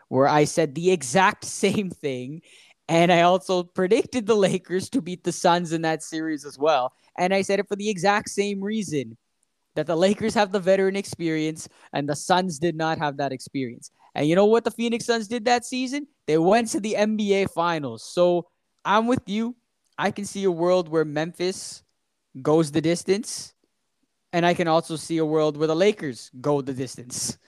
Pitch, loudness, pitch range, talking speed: 175 Hz, -23 LUFS, 155-200 Hz, 195 wpm